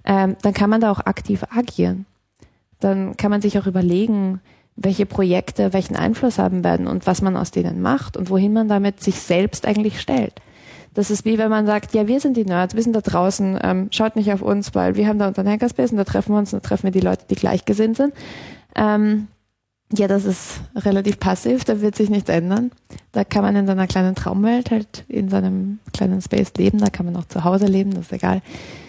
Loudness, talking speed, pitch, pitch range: -19 LUFS, 225 wpm, 200 Hz, 185-210 Hz